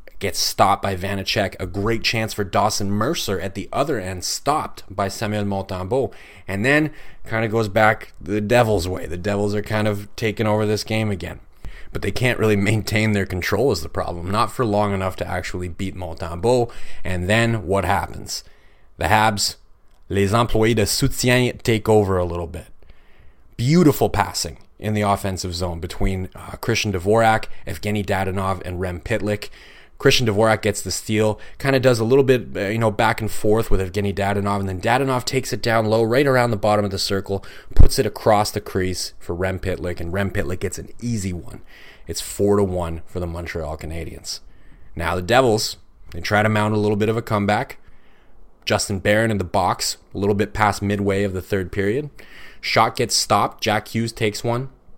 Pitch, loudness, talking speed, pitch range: 100 Hz, -21 LUFS, 190 wpm, 95-110 Hz